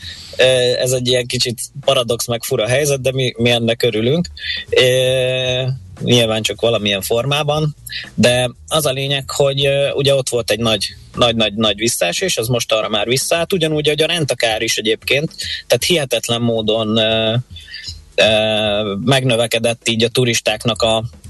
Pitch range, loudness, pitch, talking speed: 110-130 Hz, -16 LUFS, 120 Hz, 145 wpm